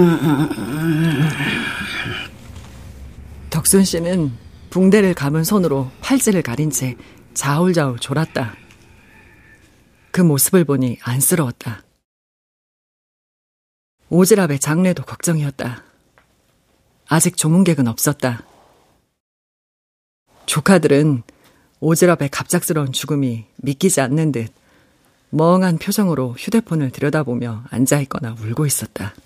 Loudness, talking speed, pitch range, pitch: -17 LUFS, 215 characters per minute, 125-170 Hz, 145 Hz